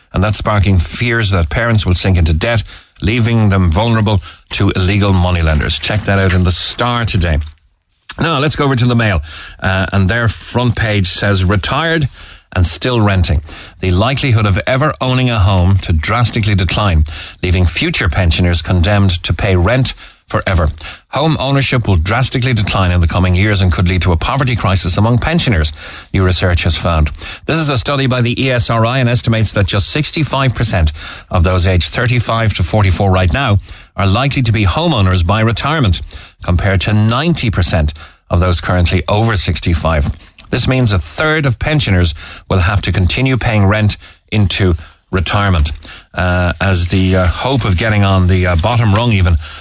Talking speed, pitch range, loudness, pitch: 170 wpm, 90-115 Hz, -13 LUFS, 95 Hz